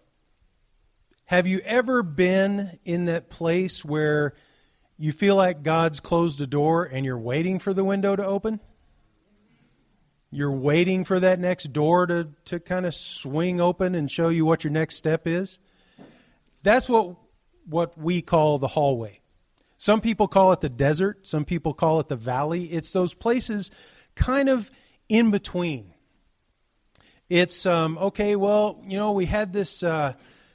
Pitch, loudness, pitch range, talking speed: 170 Hz, -24 LUFS, 150-195 Hz, 155 wpm